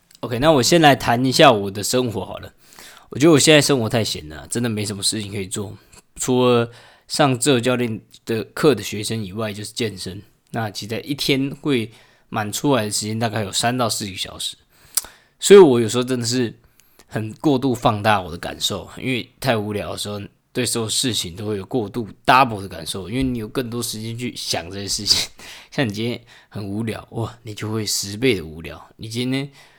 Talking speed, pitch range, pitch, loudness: 310 characters per minute, 100-125 Hz, 110 Hz, -20 LUFS